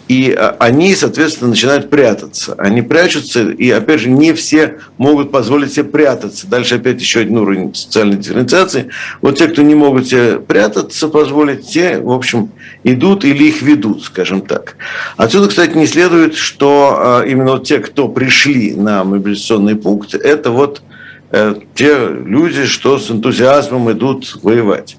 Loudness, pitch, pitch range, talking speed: -11 LUFS, 135 Hz, 115-150 Hz, 145 wpm